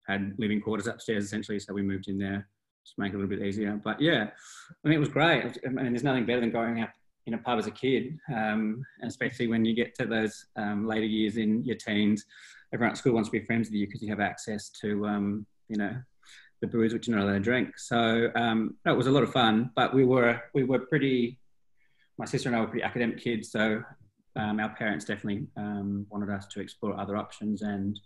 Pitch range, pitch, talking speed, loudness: 105-120 Hz, 110 Hz, 245 wpm, -29 LUFS